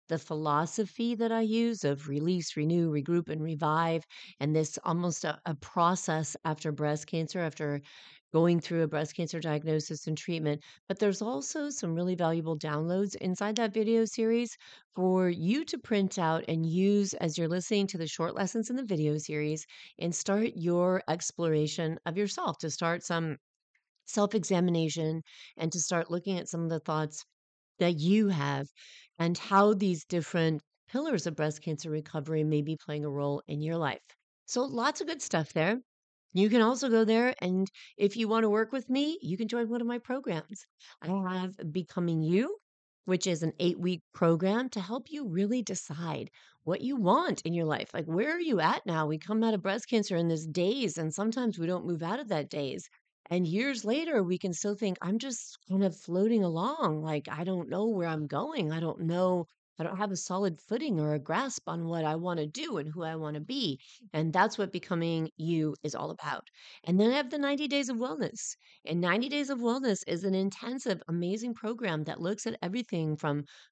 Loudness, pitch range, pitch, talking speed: -31 LUFS, 160-215 Hz, 175 Hz, 200 wpm